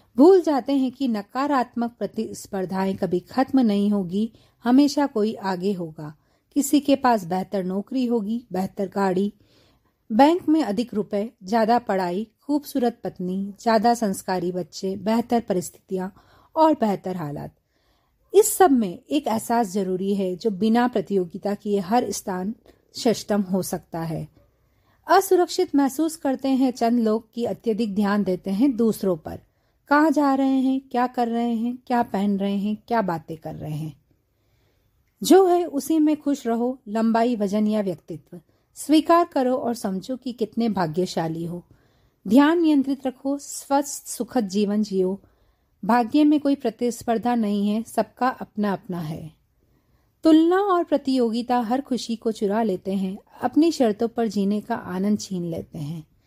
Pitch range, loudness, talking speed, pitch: 190-260 Hz, -23 LUFS, 145 wpm, 225 Hz